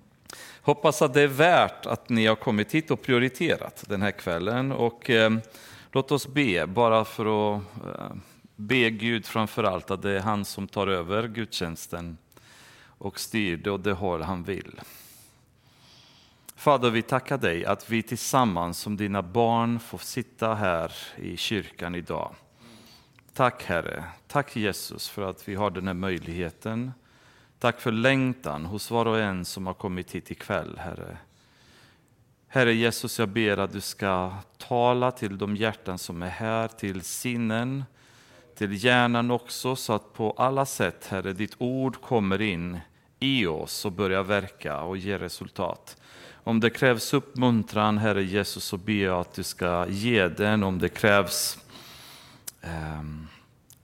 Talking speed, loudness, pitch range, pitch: 155 wpm, -26 LUFS, 95-125 Hz, 110 Hz